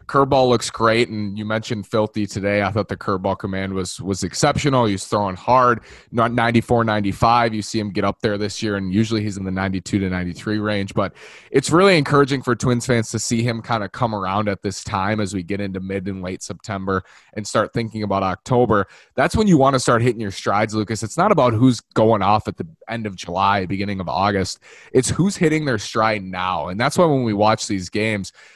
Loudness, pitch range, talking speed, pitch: -20 LUFS, 100-120 Hz, 225 wpm, 105 Hz